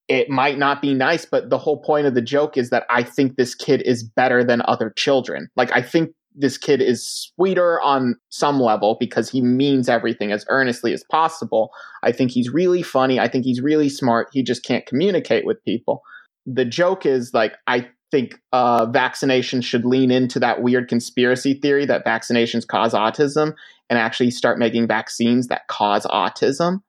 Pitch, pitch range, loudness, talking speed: 125 Hz, 120-140 Hz, -19 LUFS, 185 wpm